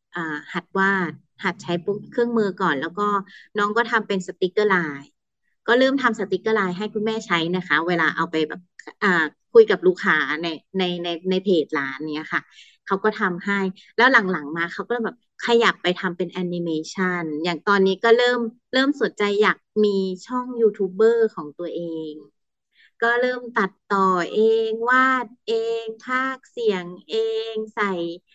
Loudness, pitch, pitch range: -22 LUFS, 195 Hz, 175-225 Hz